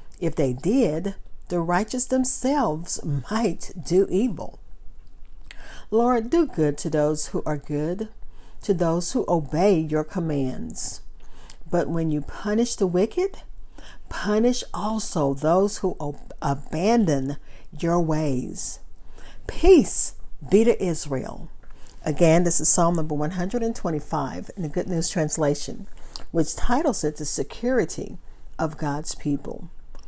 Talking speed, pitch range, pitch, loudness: 120 wpm, 150-210 Hz, 170 Hz, -23 LUFS